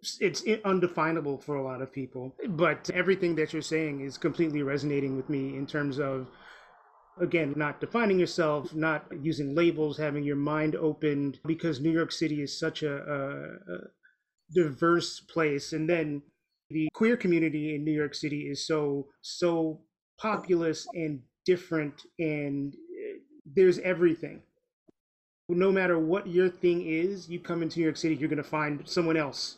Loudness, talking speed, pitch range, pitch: -29 LUFS, 155 wpm, 145-175 Hz, 160 Hz